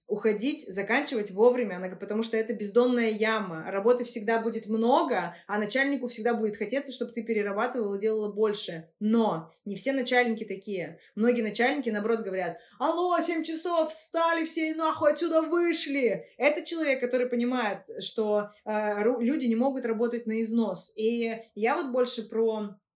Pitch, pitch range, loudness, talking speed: 230 Hz, 215-265 Hz, -28 LUFS, 150 wpm